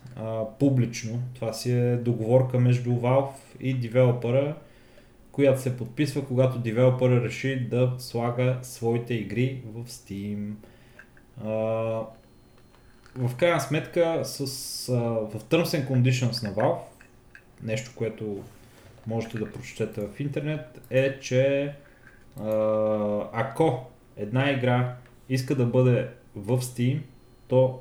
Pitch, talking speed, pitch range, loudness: 125 Hz, 115 wpm, 115-130 Hz, -26 LUFS